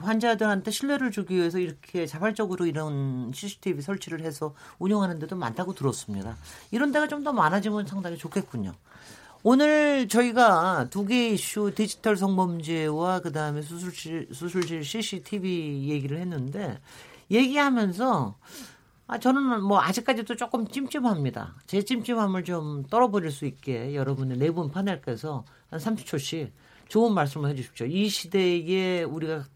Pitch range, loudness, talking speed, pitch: 155-215 Hz, -27 LUFS, 330 characters per minute, 185 Hz